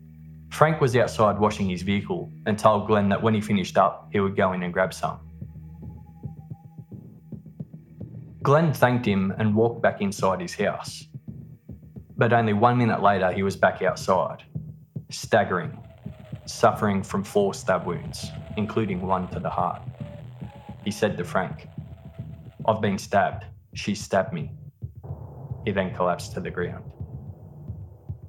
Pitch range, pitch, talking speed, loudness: 95-130 Hz, 105 Hz, 140 wpm, -24 LUFS